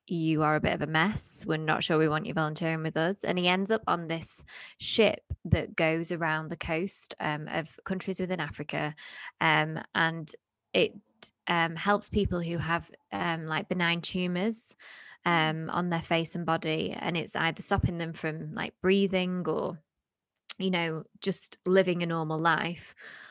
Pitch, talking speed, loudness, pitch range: 165 Hz, 175 wpm, -29 LUFS, 155-180 Hz